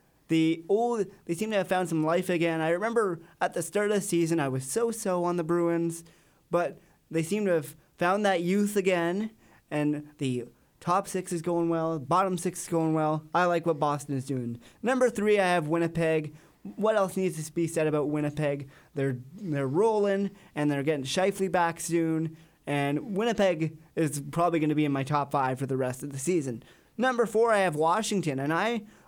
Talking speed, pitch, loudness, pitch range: 200 wpm, 170 Hz, -28 LUFS, 150-190 Hz